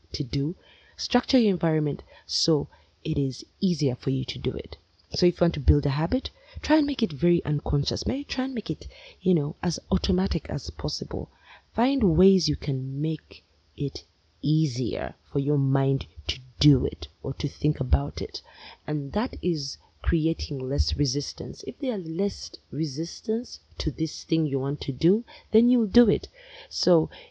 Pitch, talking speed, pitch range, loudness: 155 Hz, 175 wpm, 135-195 Hz, -26 LUFS